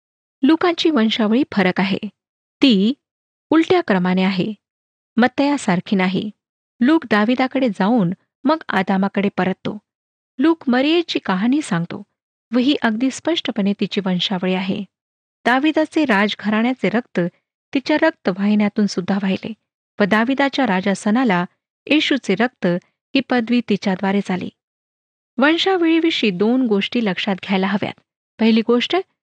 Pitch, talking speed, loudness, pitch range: 220 Hz, 110 wpm, -18 LUFS, 195-275 Hz